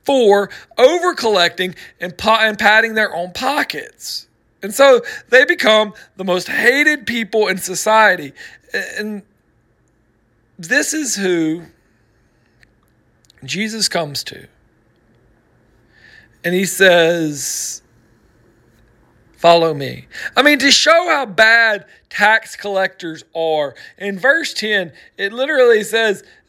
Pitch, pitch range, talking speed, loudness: 195 Hz, 160-225 Hz, 105 wpm, -15 LUFS